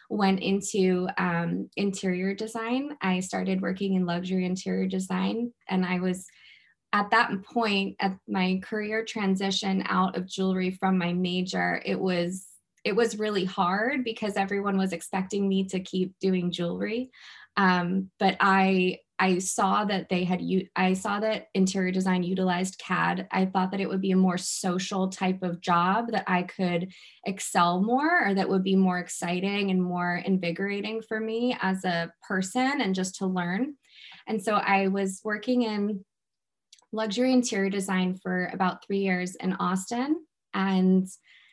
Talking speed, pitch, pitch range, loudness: 155 wpm, 190 Hz, 185-200 Hz, -27 LUFS